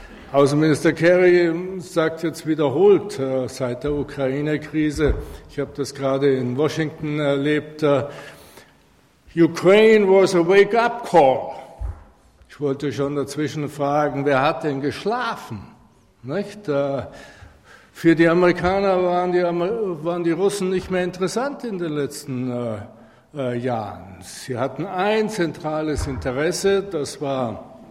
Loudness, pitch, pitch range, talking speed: -20 LUFS, 150 Hz, 135-180 Hz, 125 wpm